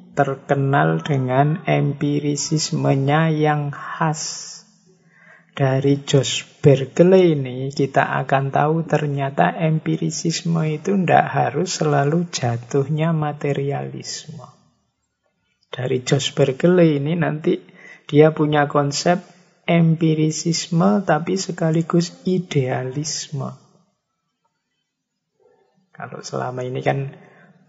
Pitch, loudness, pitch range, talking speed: 155 Hz, -19 LUFS, 140-170 Hz, 80 wpm